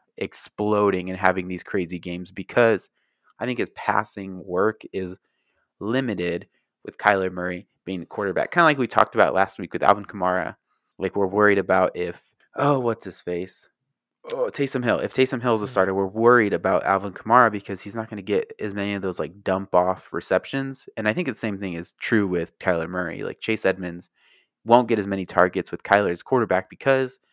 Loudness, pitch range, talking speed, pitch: -23 LUFS, 90-115 Hz, 200 wpm, 100 Hz